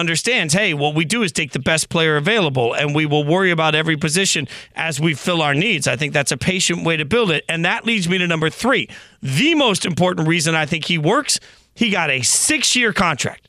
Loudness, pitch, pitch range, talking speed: -17 LUFS, 165 Hz, 155-190 Hz, 235 wpm